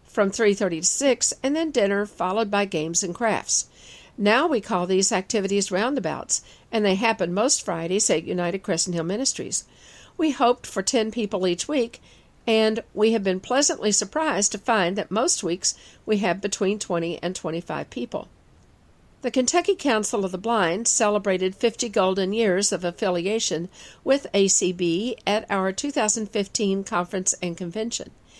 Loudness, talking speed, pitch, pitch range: -23 LUFS, 155 wpm, 200 Hz, 180-225 Hz